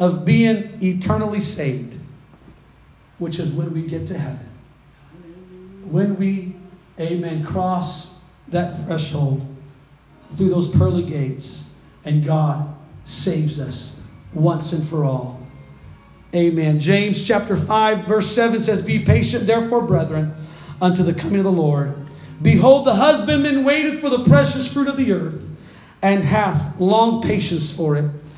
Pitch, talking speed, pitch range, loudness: 170 Hz, 135 wpm, 145-195 Hz, -19 LUFS